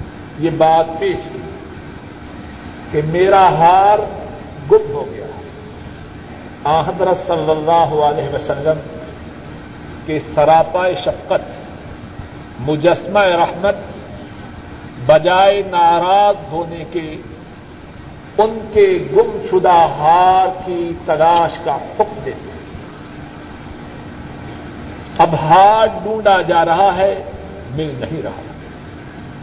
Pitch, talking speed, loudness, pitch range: 175 Hz, 90 wpm, -14 LUFS, 155-200 Hz